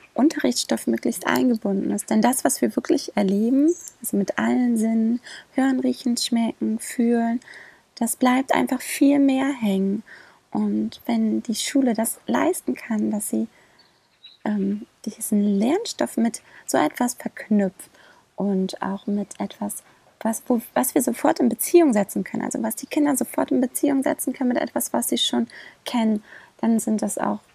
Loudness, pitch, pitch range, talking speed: -23 LUFS, 235 Hz, 210-270 Hz, 155 wpm